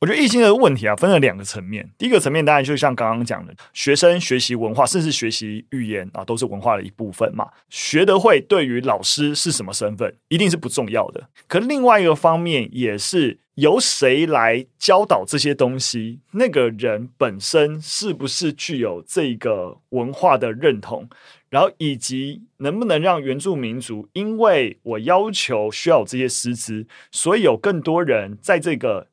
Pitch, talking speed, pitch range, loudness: 135 Hz, 280 characters per minute, 115-170 Hz, -19 LUFS